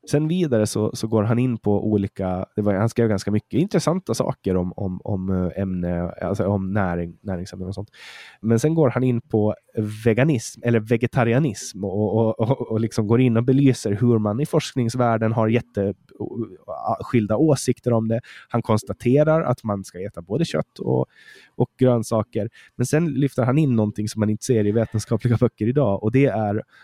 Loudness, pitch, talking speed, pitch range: -22 LUFS, 115 Hz, 185 wpm, 105-125 Hz